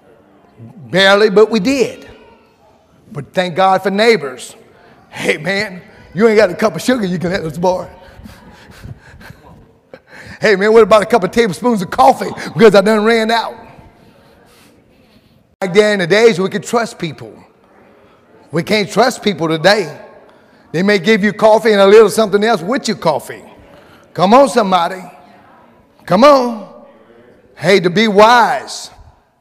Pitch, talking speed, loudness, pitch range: 205 Hz, 150 wpm, -12 LUFS, 185-225 Hz